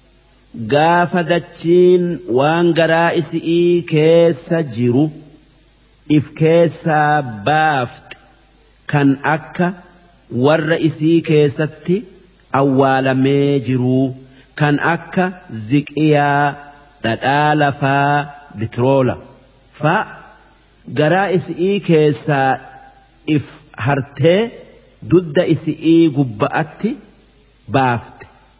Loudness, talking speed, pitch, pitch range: -15 LUFS, 70 wpm, 155 Hz, 140-170 Hz